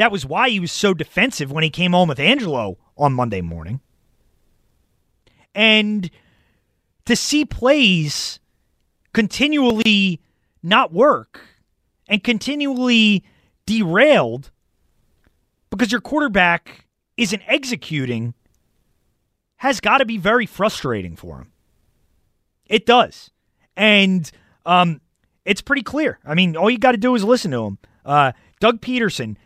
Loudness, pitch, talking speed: -17 LUFS, 180 Hz, 120 wpm